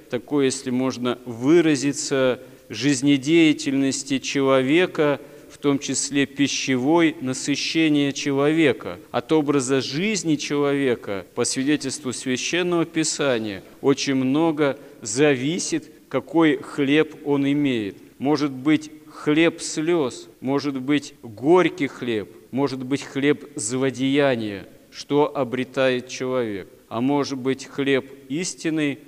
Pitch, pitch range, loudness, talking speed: 140 Hz, 130-150 Hz, -22 LUFS, 95 wpm